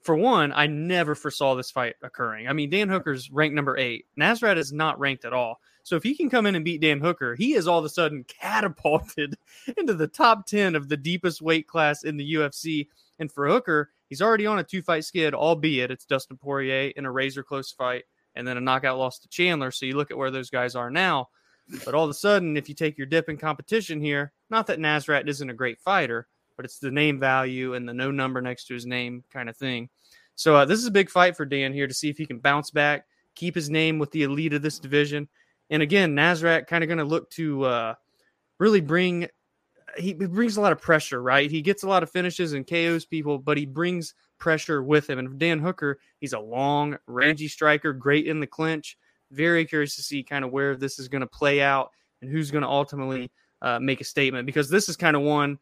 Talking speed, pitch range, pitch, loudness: 240 wpm, 135-165 Hz, 150 Hz, -24 LUFS